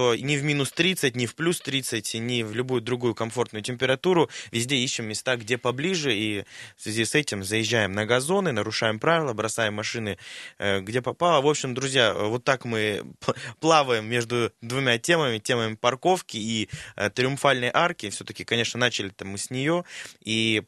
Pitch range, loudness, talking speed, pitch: 110-140 Hz, -25 LUFS, 165 wpm, 120 Hz